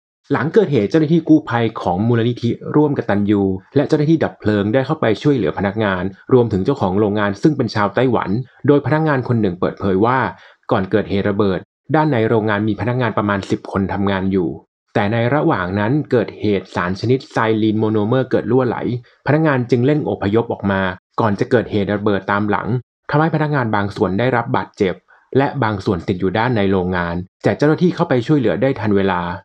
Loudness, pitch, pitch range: -17 LUFS, 110 Hz, 100-135 Hz